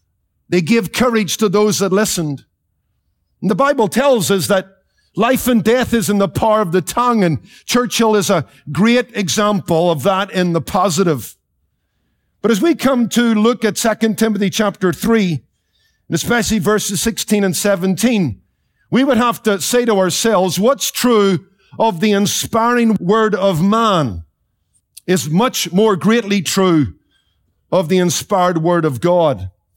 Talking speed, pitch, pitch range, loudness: 155 wpm, 200 Hz, 175-225 Hz, -15 LUFS